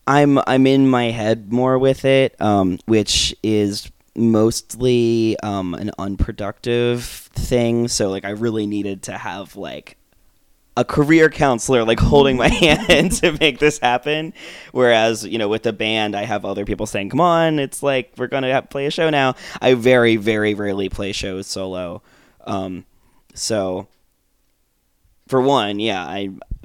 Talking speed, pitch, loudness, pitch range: 160 wpm, 115 Hz, -18 LUFS, 100-130 Hz